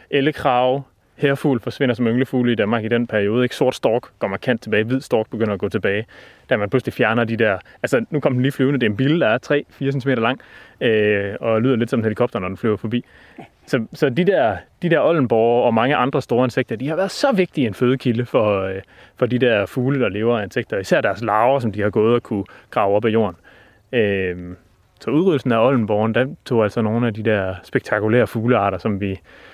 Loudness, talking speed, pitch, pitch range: -19 LUFS, 220 wpm, 120 Hz, 110-130 Hz